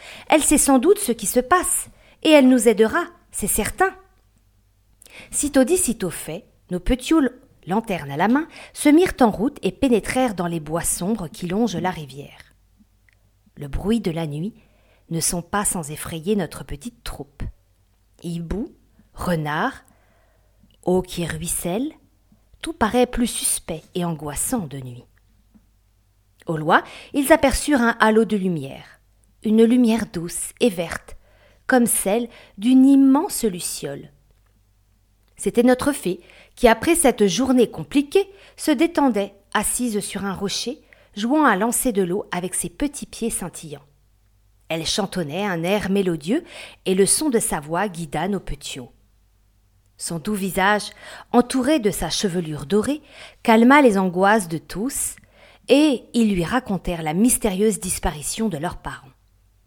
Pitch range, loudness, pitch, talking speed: 155-245 Hz, -20 LUFS, 195 Hz, 145 wpm